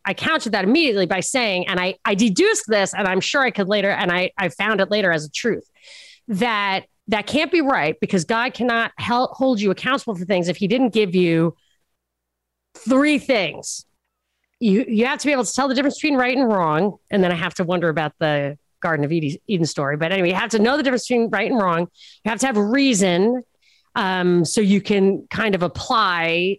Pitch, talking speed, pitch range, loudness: 200 Hz, 220 wpm, 180-240 Hz, -19 LUFS